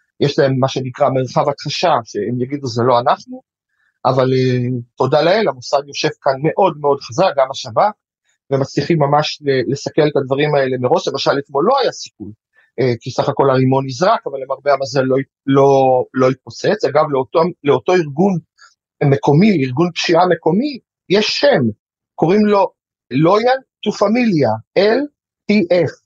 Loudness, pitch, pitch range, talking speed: -16 LUFS, 140 Hz, 130-175 Hz, 145 wpm